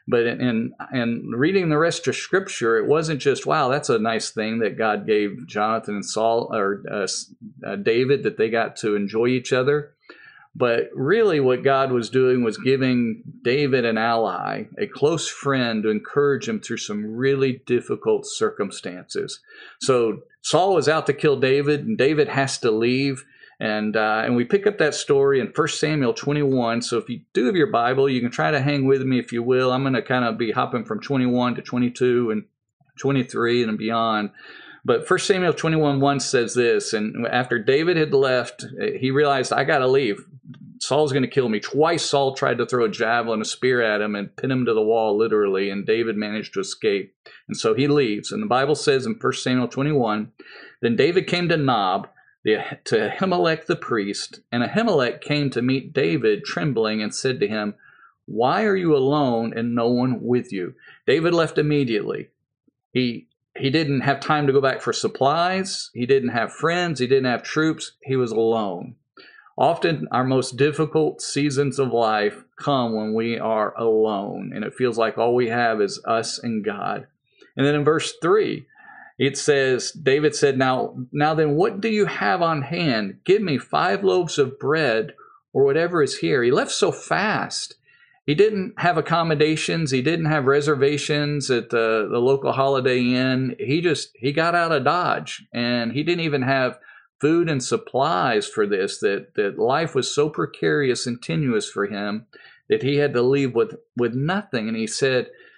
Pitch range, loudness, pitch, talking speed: 120-160 Hz, -21 LUFS, 135 Hz, 190 wpm